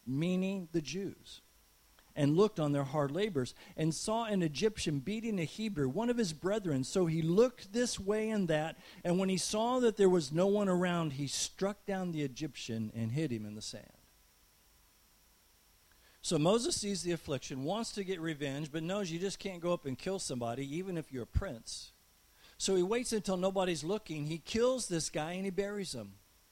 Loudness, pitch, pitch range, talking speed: -35 LUFS, 175 Hz, 145-200 Hz, 195 wpm